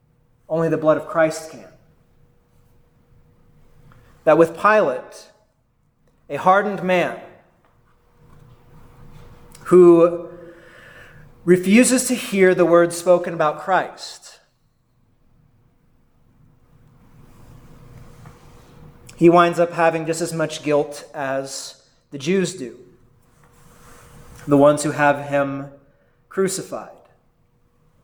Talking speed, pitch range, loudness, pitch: 85 wpm, 145-175 Hz, -18 LUFS, 155 Hz